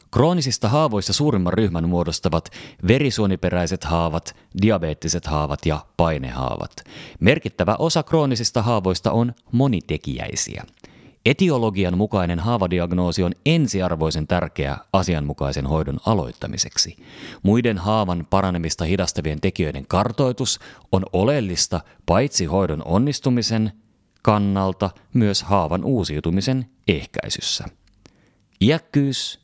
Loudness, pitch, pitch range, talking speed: -21 LUFS, 95 Hz, 85-120 Hz, 90 wpm